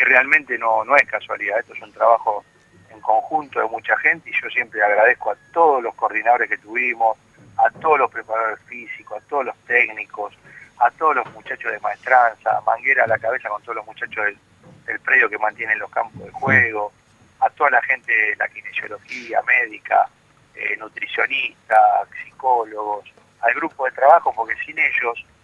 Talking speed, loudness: 175 wpm, -19 LUFS